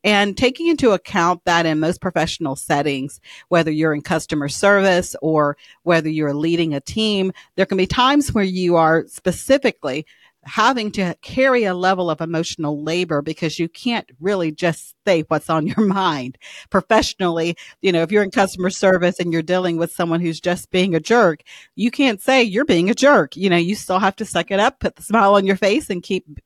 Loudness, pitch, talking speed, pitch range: -18 LUFS, 180 Hz, 200 wpm, 160-200 Hz